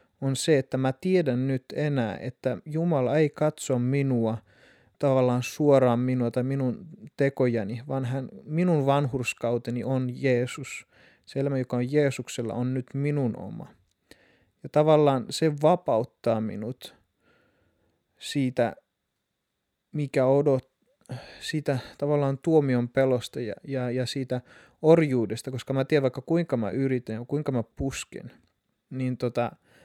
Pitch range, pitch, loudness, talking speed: 125-145 Hz, 130 Hz, -26 LUFS, 125 wpm